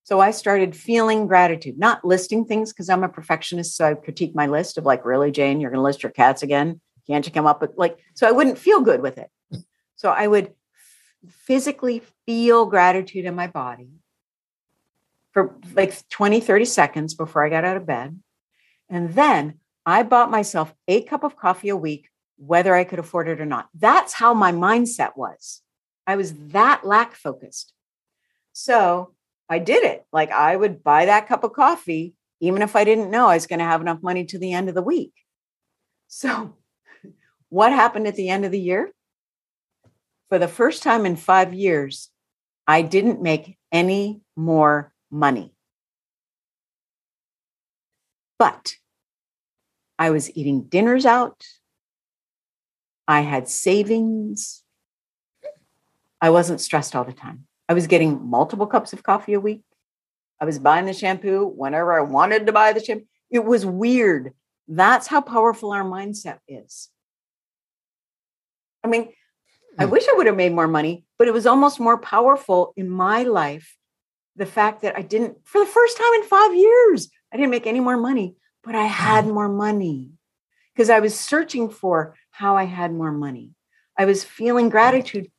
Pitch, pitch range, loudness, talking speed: 190 Hz, 160-225 Hz, -19 LUFS, 170 wpm